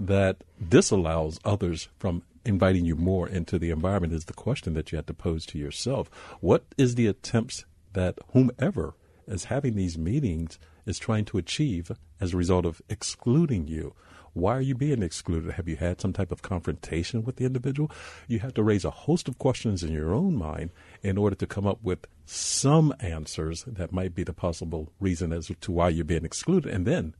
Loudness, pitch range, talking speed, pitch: -28 LUFS, 80-110 Hz, 195 wpm, 90 Hz